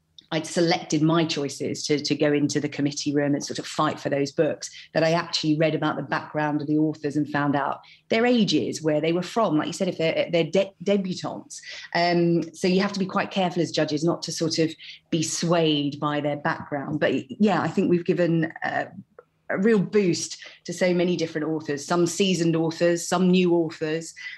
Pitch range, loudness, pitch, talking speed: 150-175 Hz, -24 LUFS, 160 Hz, 210 wpm